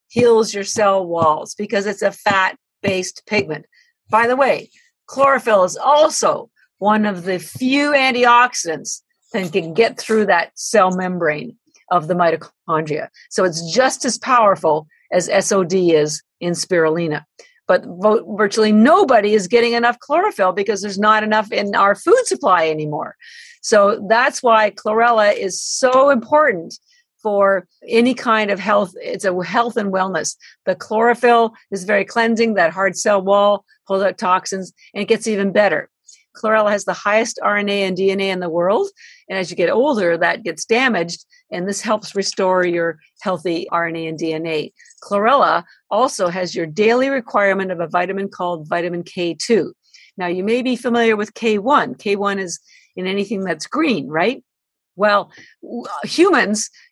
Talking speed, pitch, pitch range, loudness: 155 wpm, 205 Hz, 185-235 Hz, -17 LUFS